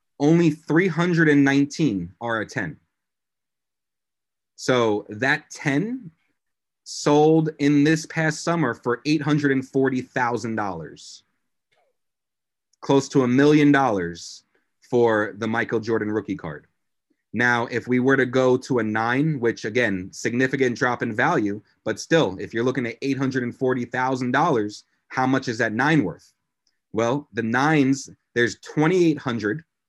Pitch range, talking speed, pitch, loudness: 115-145 Hz, 120 wpm, 130 Hz, -22 LUFS